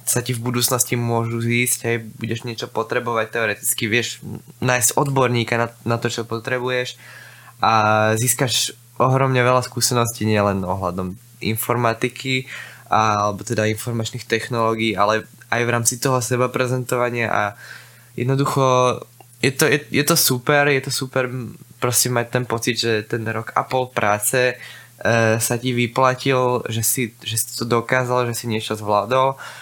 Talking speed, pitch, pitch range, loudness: 150 wpm, 120 Hz, 115-125 Hz, -19 LUFS